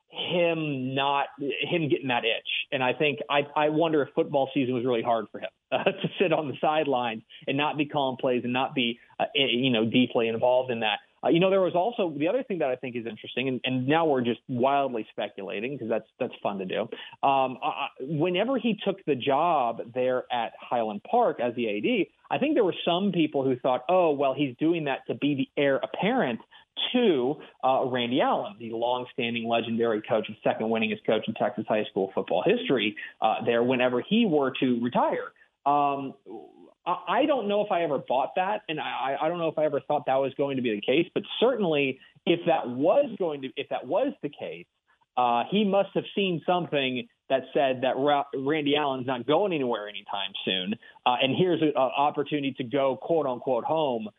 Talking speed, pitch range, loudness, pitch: 210 wpm, 125-160 Hz, -27 LUFS, 140 Hz